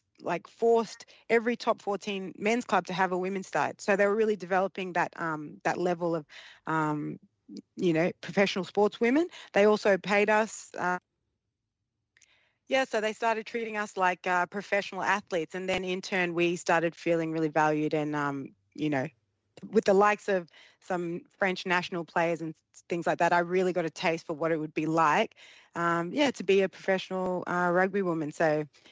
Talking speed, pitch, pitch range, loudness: 185 wpm, 185 Hz, 165-200 Hz, -29 LUFS